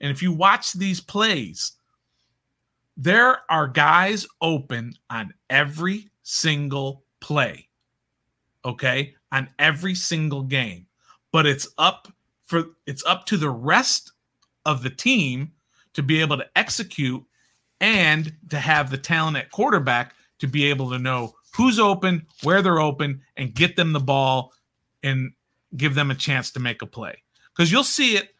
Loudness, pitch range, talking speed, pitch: -21 LUFS, 135-175 Hz, 150 wpm, 150 Hz